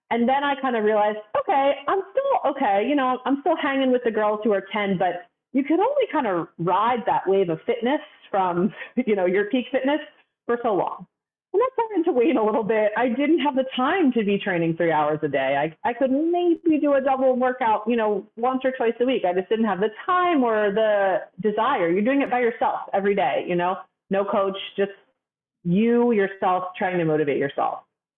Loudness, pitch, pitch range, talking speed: -22 LUFS, 230 Hz, 195-275 Hz, 220 wpm